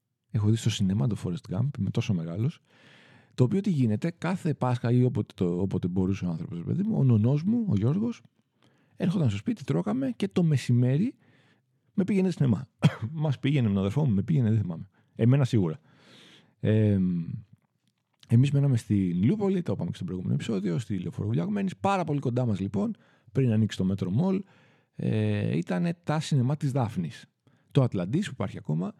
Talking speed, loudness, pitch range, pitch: 180 wpm, -27 LUFS, 110-165 Hz, 130 Hz